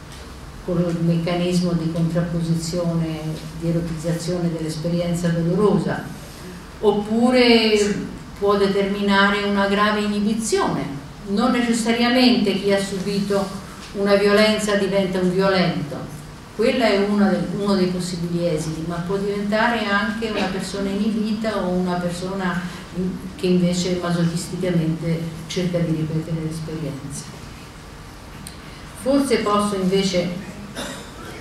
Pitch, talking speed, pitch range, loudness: 190 Hz, 95 wpm, 170-205 Hz, -21 LUFS